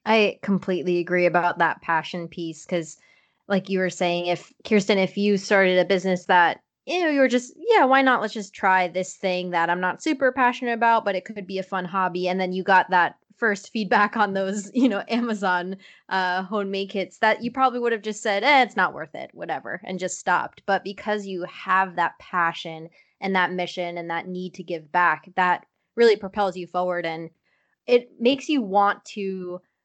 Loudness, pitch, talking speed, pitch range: -23 LUFS, 190 Hz, 210 wpm, 180-215 Hz